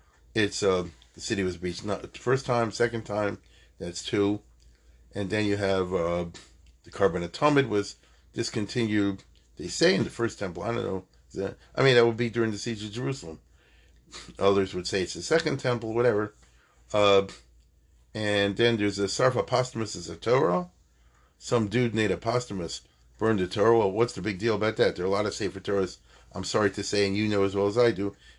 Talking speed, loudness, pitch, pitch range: 200 wpm, -27 LUFS, 100 Hz, 90-115 Hz